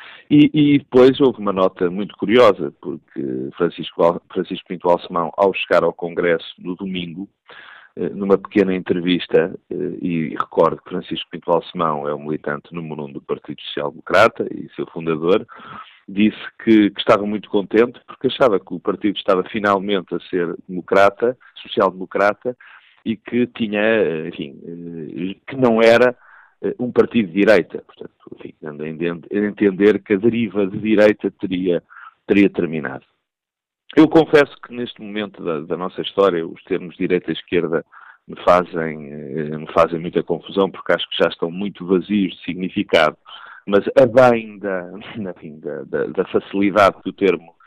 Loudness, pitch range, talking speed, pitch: -18 LUFS, 85-110 Hz, 150 wpm, 100 Hz